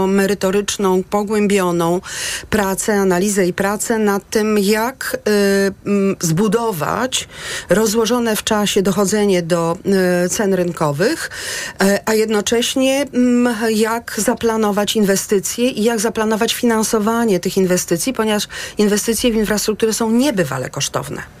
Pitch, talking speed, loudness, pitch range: 210 Hz, 100 wpm, -17 LUFS, 195-225 Hz